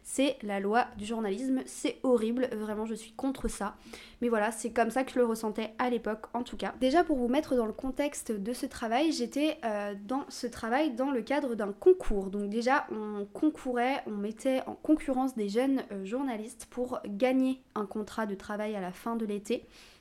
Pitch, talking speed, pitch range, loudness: 240 Hz, 200 wpm, 215-265 Hz, -31 LUFS